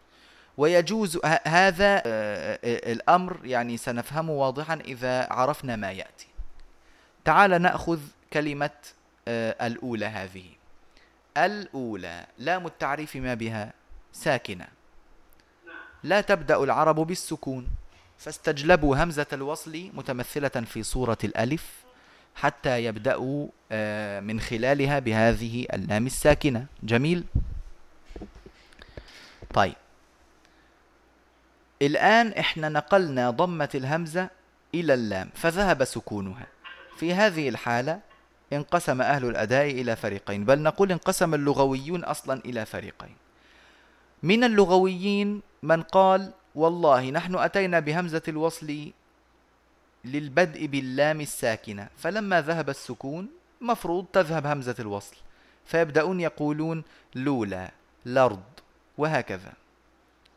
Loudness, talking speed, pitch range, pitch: -26 LUFS, 90 wpm, 120-170 Hz, 145 Hz